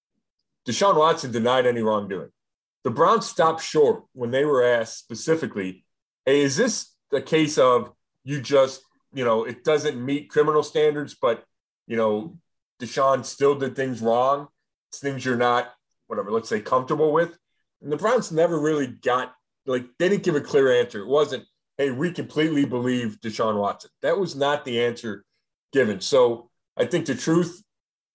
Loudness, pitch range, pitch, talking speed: -23 LUFS, 120-155 Hz, 135 Hz, 165 wpm